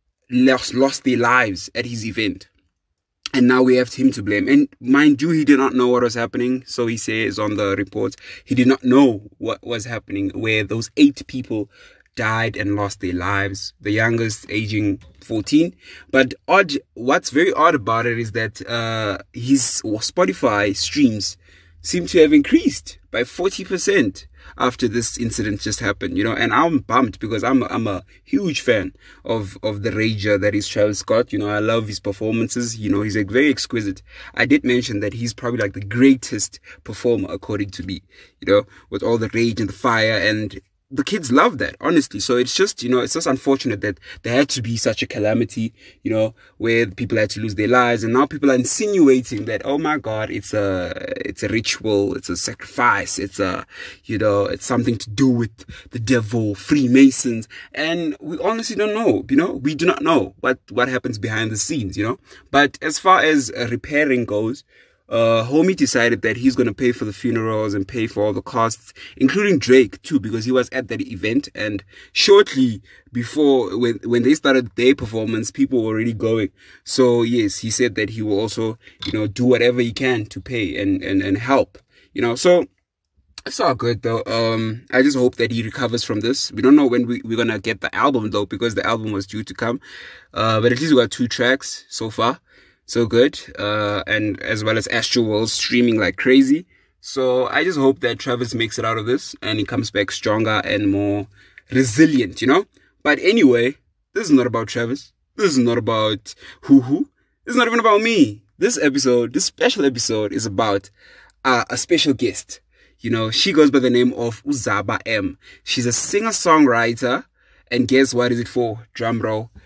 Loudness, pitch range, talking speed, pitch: -18 LUFS, 105-130 Hz, 200 wpm, 115 Hz